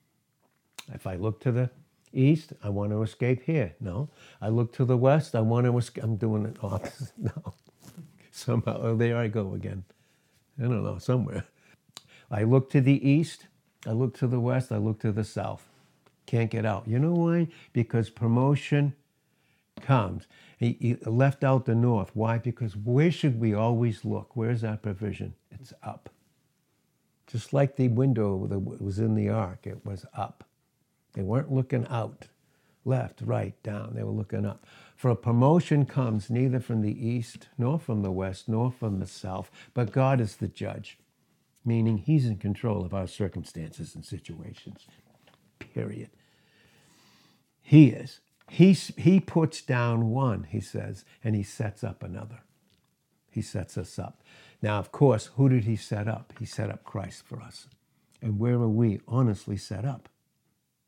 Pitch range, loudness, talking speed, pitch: 110-135 Hz, -27 LUFS, 170 wpm, 115 Hz